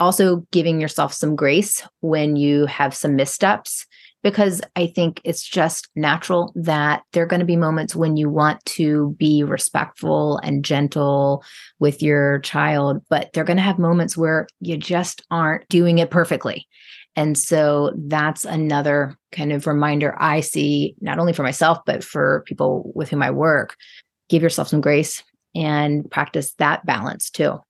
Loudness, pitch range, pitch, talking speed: -19 LUFS, 145-170 Hz, 155 Hz, 165 wpm